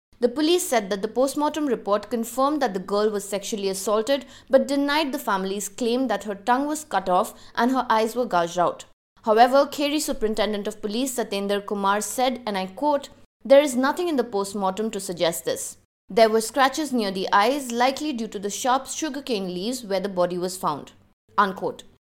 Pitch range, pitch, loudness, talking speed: 200-270 Hz, 230 Hz, -23 LUFS, 190 wpm